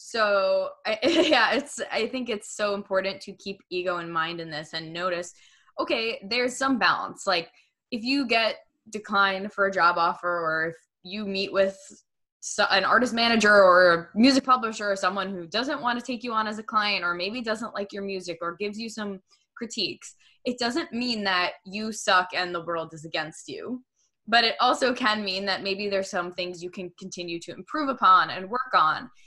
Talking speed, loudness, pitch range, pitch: 200 wpm, -25 LUFS, 180-235 Hz, 200 Hz